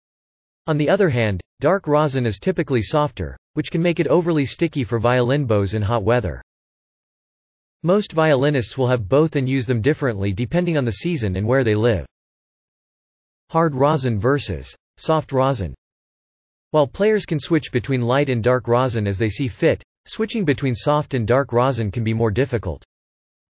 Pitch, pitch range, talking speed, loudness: 125 Hz, 105-150 Hz, 170 wpm, -20 LUFS